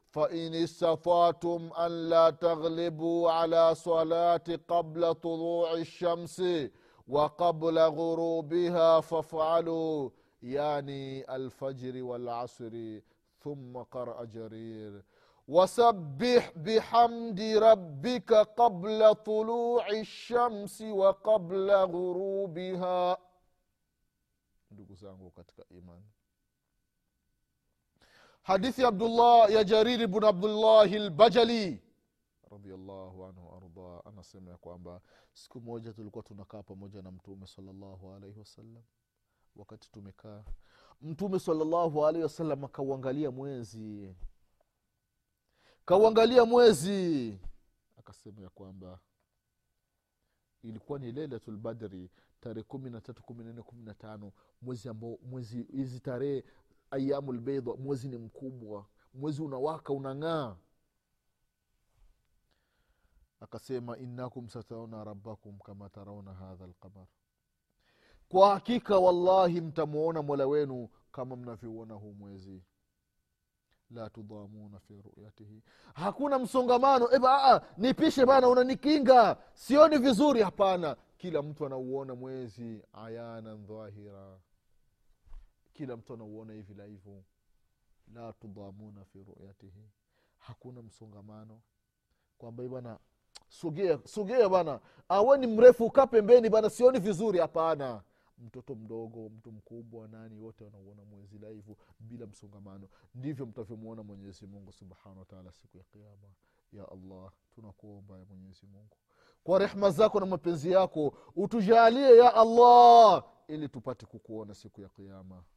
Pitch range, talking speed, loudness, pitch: 105-175 Hz, 75 wpm, -26 LUFS, 125 Hz